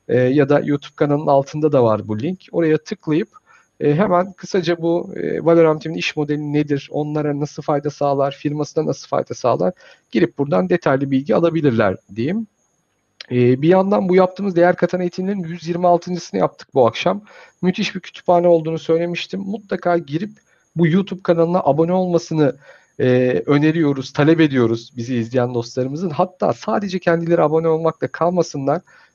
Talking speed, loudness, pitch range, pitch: 140 wpm, -18 LUFS, 145-180 Hz, 160 Hz